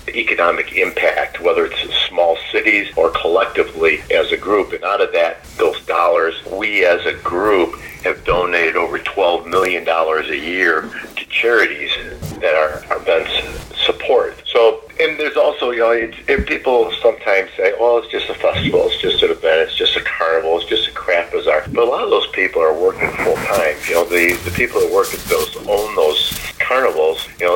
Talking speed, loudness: 190 wpm, -16 LUFS